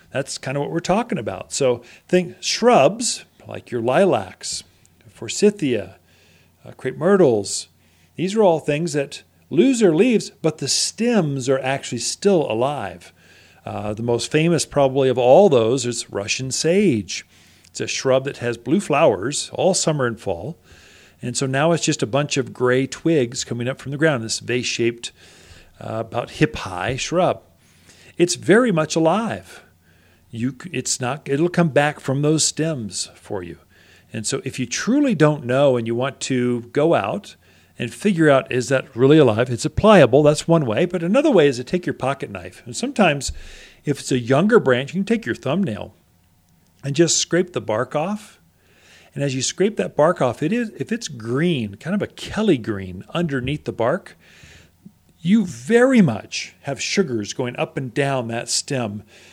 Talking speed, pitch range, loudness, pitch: 180 wpm, 115-165 Hz, -20 LUFS, 135 Hz